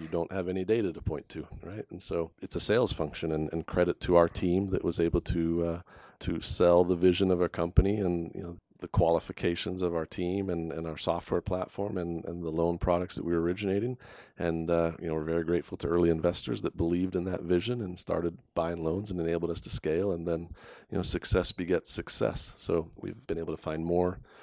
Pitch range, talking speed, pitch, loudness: 85-90 Hz, 230 wpm, 85 Hz, -30 LUFS